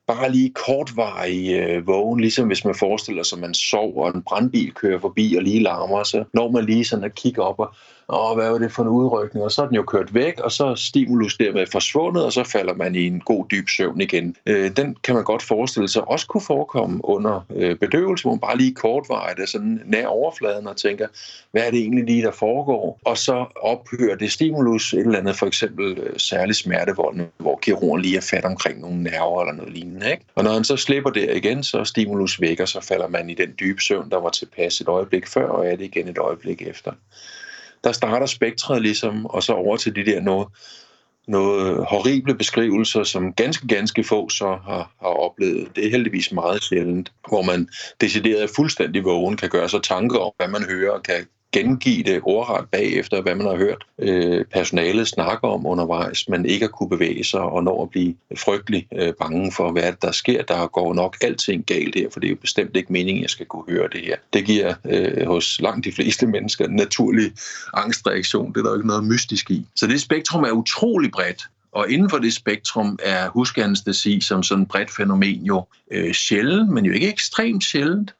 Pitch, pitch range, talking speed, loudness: 110 Hz, 95-130 Hz, 205 wpm, -20 LUFS